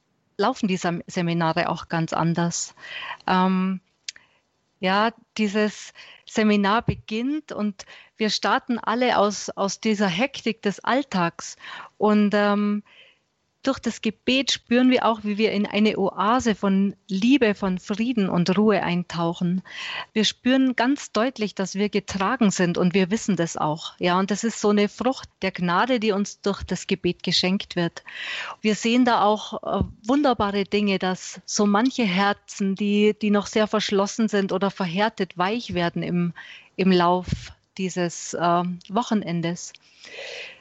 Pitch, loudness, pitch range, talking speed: 205 Hz, -23 LUFS, 185-225 Hz, 140 wpm